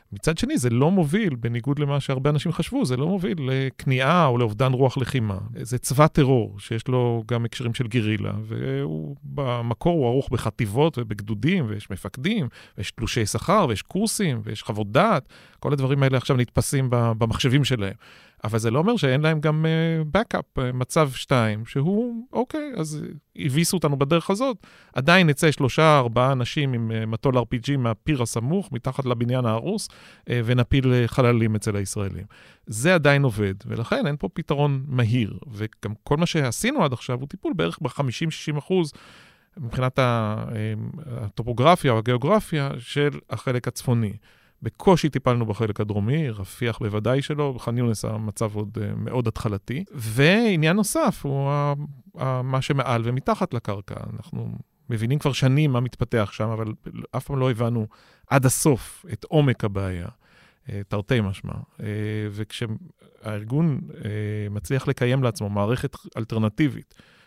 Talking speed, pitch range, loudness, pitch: 140 wpm, 115-150 Hz, -23 LUFS, 125 Hz